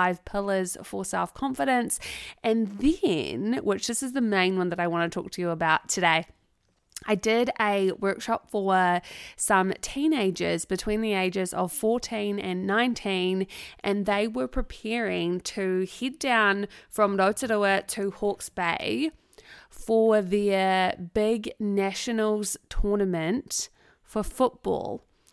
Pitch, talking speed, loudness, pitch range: 205 Hz, 130 wpm, -26 LUFS, 185-225 Hz